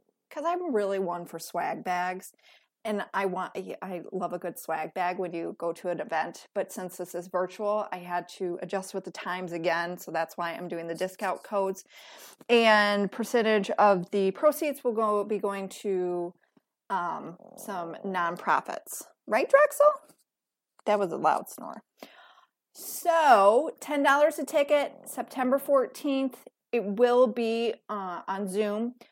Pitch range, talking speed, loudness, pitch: 180-240 Hz, 155 wpm, -28 LUFS, 200 Hz